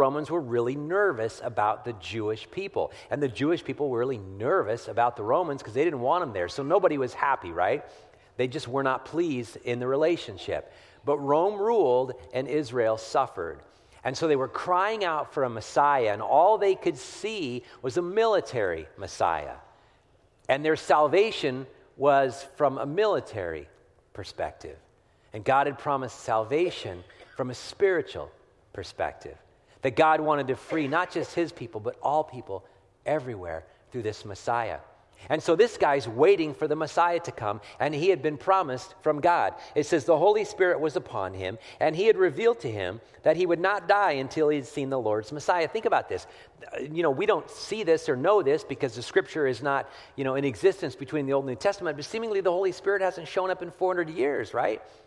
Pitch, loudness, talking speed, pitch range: 145 Hz, -27 LUFS, 190 wpm, 125-185 Hz